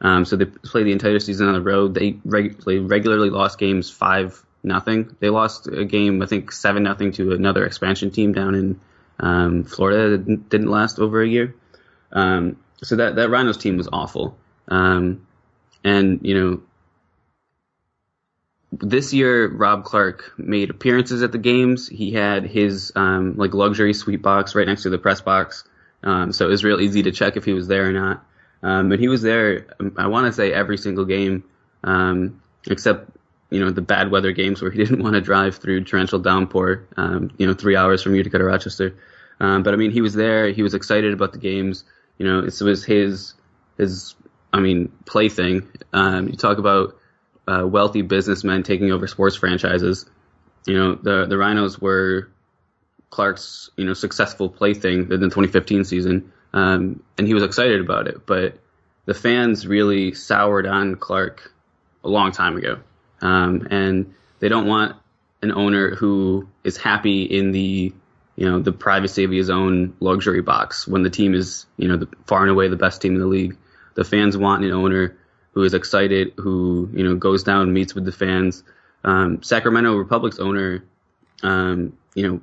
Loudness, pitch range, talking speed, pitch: -19 LUFS, 95-105 Hz, 185 wpm, 95 Hz